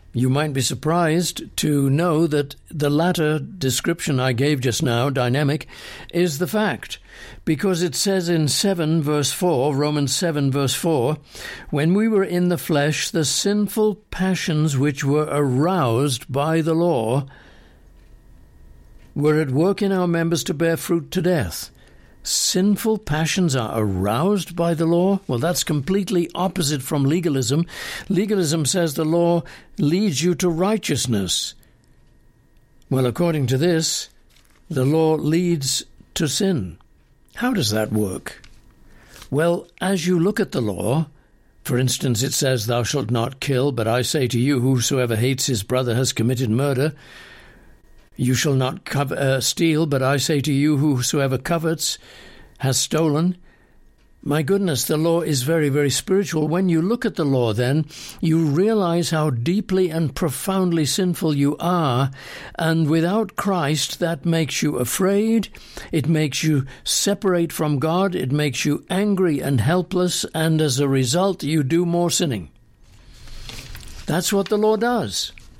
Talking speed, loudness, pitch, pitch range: 150 wpm, -20 LUFS, 155 Hz, 135-175 Hz